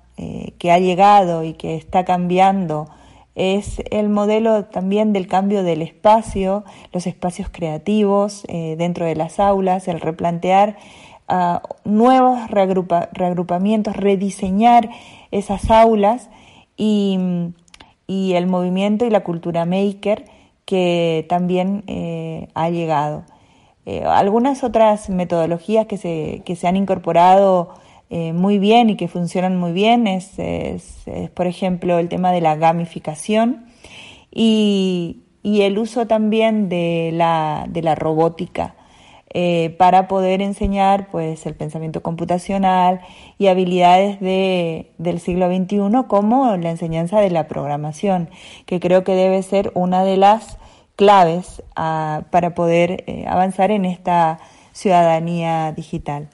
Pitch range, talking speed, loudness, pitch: 170-205 Hz, 125 wpm, -17 LUFS, 185 Hz